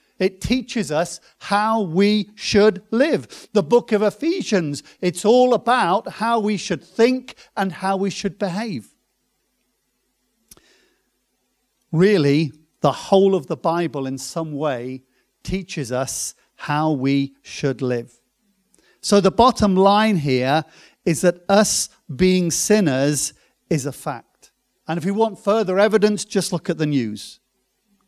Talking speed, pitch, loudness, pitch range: 135 wpm, 190 Hz, -20 LUFS, 155-210 Hz